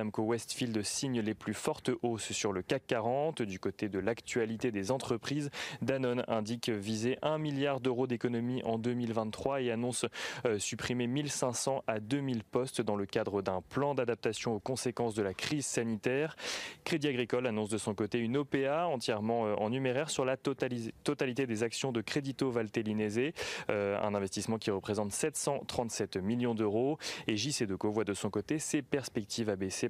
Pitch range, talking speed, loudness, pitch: 110-135 Hz, 170 wpm, -34 LUFS, 120 Hz